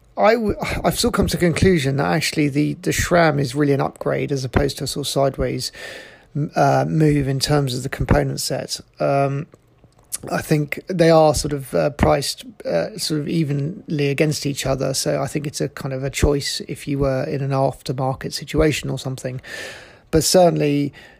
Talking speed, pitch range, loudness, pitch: 195 wpm, 135-155 Hz, -20 LUFS, 145 Hz